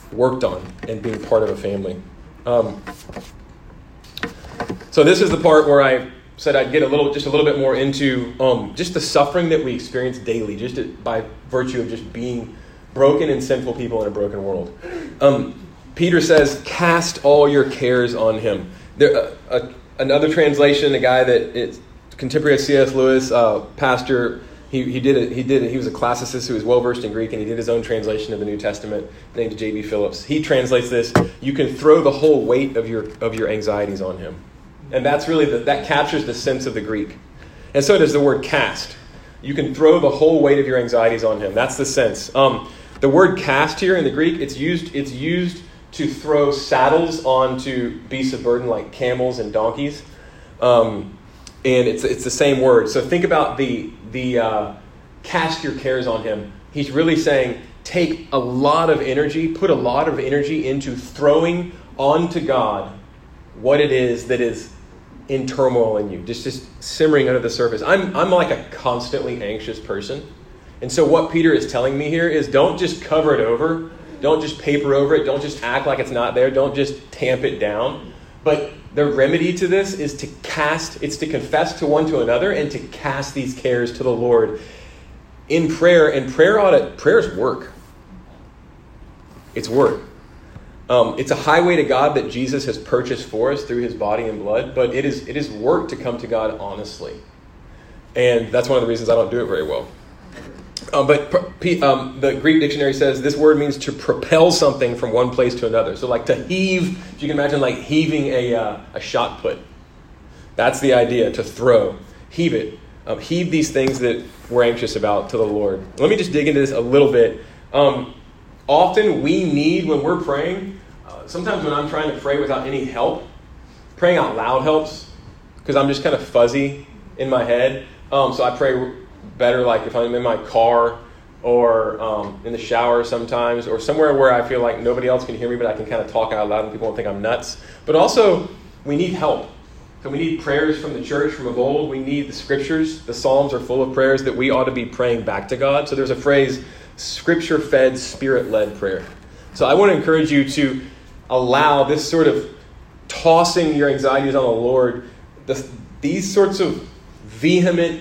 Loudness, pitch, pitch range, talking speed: -18 LUFS, 135 Hz, 120-155 Hz, 200 wpm